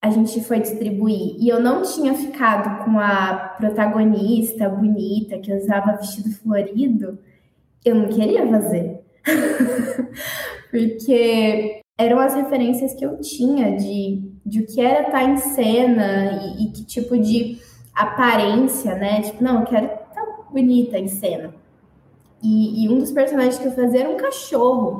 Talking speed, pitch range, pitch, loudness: 145 wpm, 210-255 Hz, 225 Hz, -19 LUFS